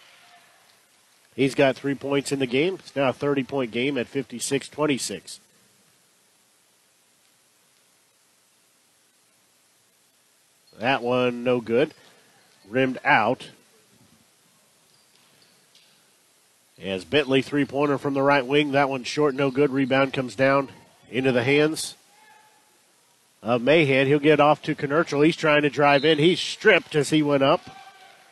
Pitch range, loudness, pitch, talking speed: 110-145 Hz, -22 LUFS, 135 Hz, 125 wpm